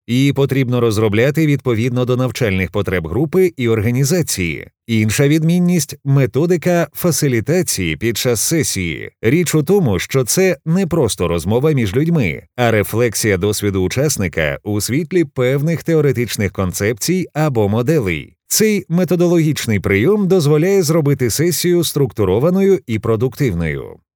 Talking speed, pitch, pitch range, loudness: 115 wpm, 135 Hz, 110-165 Hz, -16 LUFS